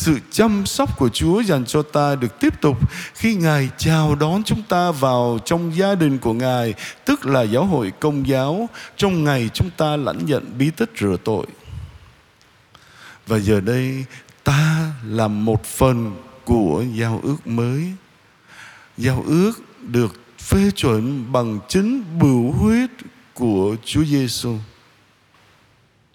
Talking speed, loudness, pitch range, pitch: 145 wpm, -19 LUFS, 120-170 Hz, 135 Hz